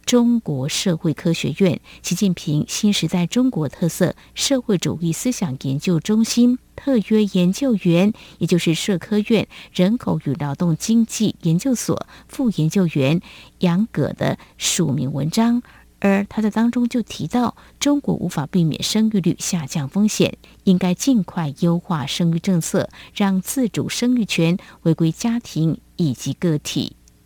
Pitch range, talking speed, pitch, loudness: 165-220 Hz, 230 characters per minute, 185 Hz, -20 LUFS